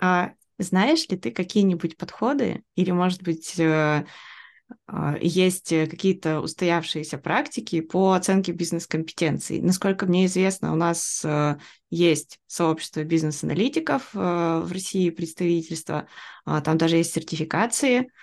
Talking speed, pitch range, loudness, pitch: 100 wpm, 160-190 Hz, -24 LUFS, 175 Hz